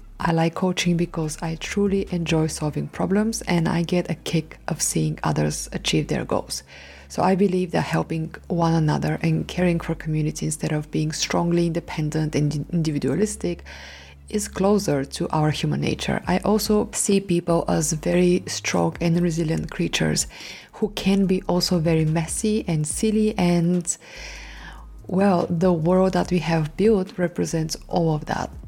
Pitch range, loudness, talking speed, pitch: 155-185 Hz, -23 LUFS, 155 wpm, 170 Hz